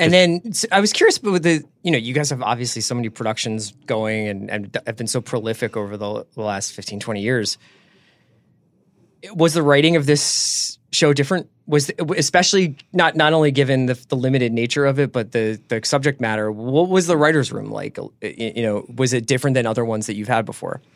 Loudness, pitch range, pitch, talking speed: -19 LUFS, 110-155 Hz, 130 Hz, 215 wpm